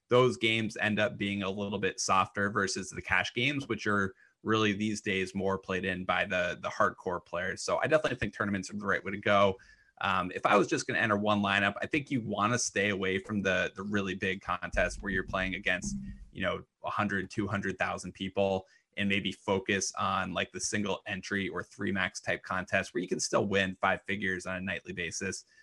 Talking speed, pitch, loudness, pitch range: 215 wpm, 100 Hz, -31 LUFS, 95-105 Hz